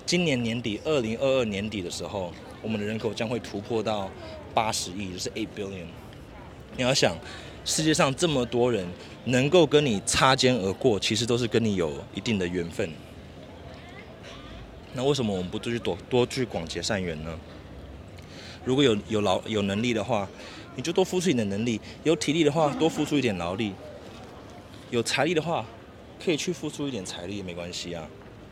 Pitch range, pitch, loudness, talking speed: 95-130 Hz, 110 Hz, -26 LUFS, 280 characters per minute